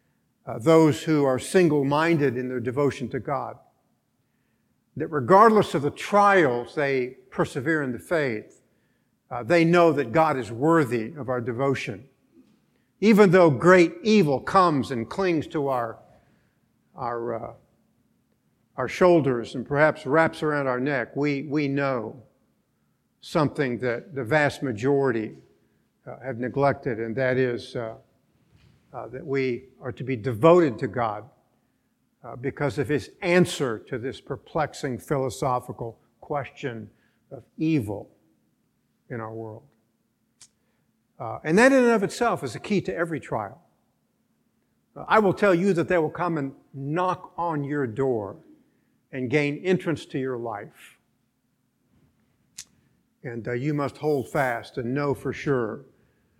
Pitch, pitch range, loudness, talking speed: 140 Hz, 125-165 Hz, -24 LUFS, 140 wpm